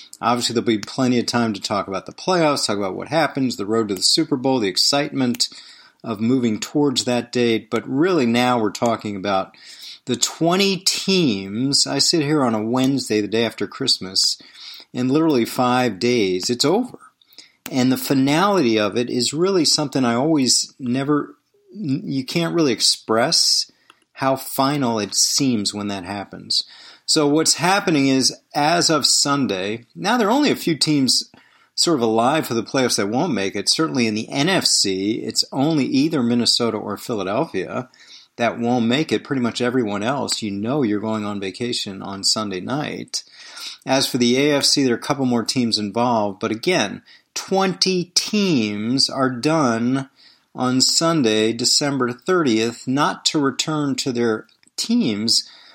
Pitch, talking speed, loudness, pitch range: 125 Hz, 165 wpm, -19 LUFS, 110-145 Hz